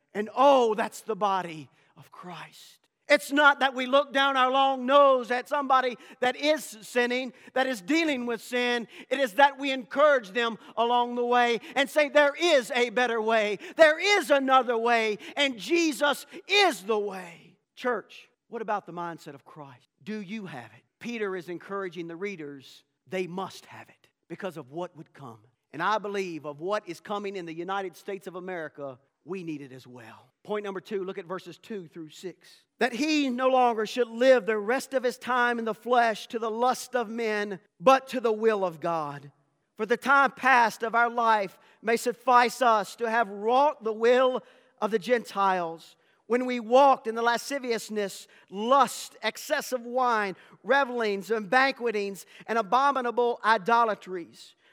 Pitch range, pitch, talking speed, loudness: 190-255 Hz, 230 Hz, 175 wpm, -26 LUFS